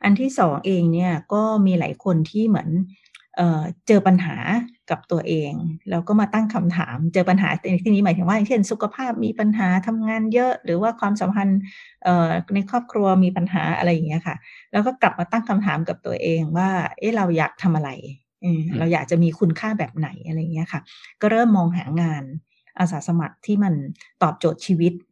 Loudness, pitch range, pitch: -21 LUFS, 170-210 Hz, 185 Hz